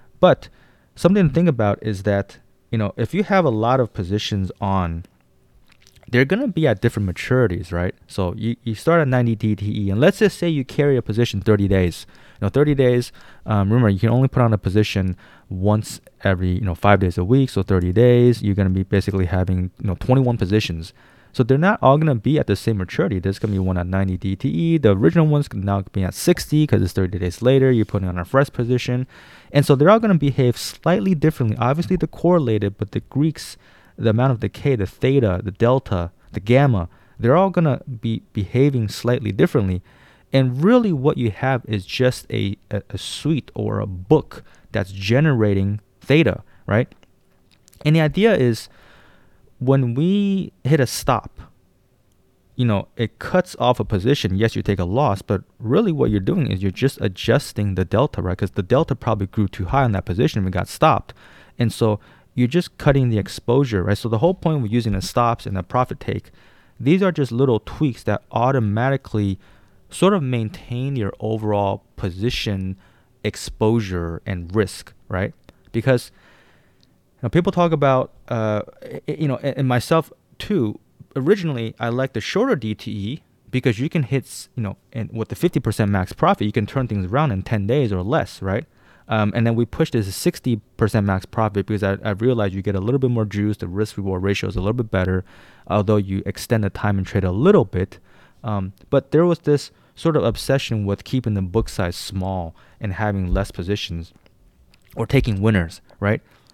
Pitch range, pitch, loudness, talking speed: 100-135 Hz, 110 Hz, -20 LUFS, 195 wpm